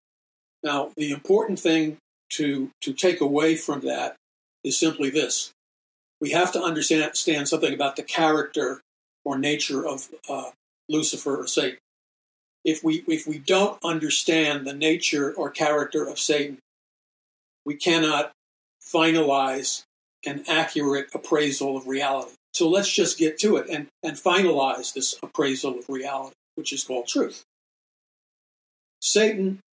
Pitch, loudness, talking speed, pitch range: 155 Hz, -24 LUFS, 135 wpm, 140-165 Hz